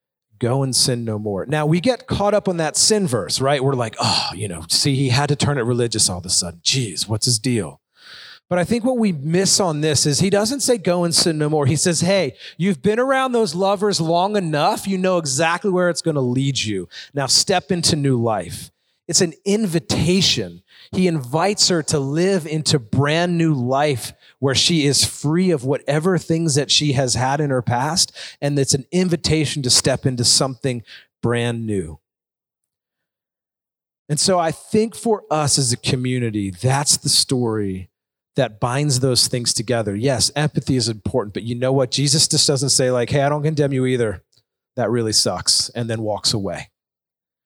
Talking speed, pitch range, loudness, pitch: 195 wpm, 120-170 Hz, -18 LUFS, 140 Hz